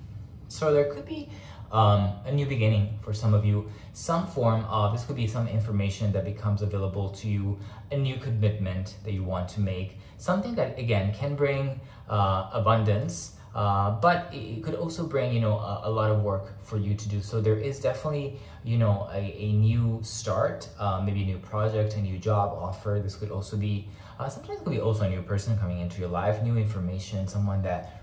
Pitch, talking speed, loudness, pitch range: 105 Hz, 210 wpm, -28 LUFS, 100-115 Hz